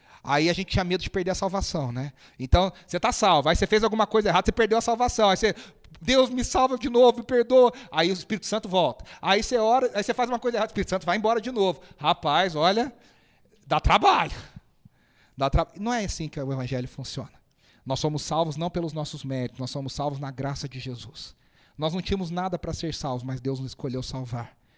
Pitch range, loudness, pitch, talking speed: 135-220 Hz, -25 LUFS, 175 Hz, 225 wpm